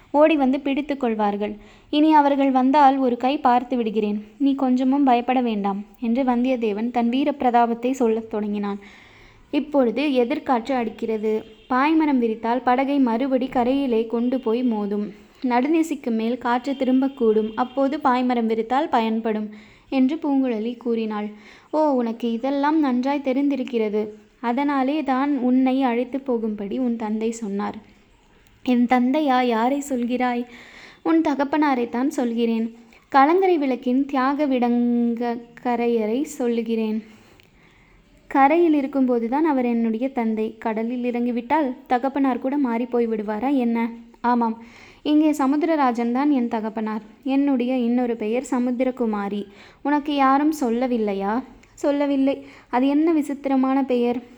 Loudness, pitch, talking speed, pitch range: -22 LUFS, 250 Hz, 110 wpm, 230-275 Hz